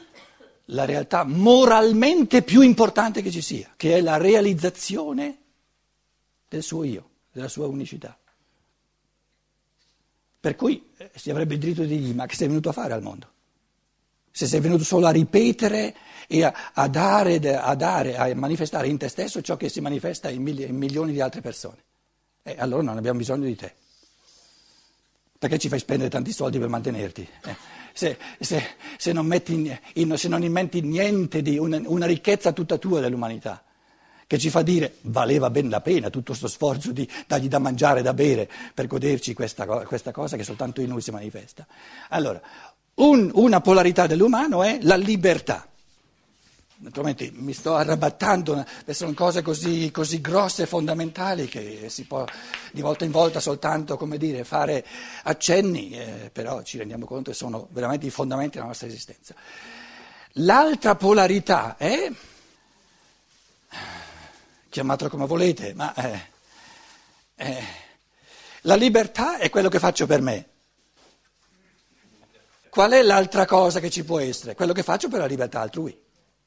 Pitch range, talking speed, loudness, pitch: 140-185 Hz, 155 wpm, -22 LUFS, 160 Hz